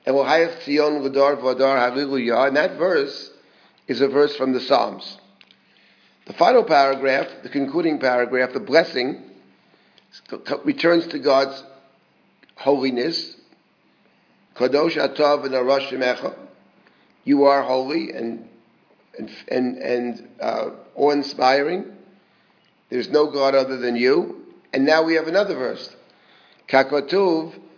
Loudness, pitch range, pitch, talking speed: -20 LUFS, 130-150 Hz, 135 Hz, 90 wpm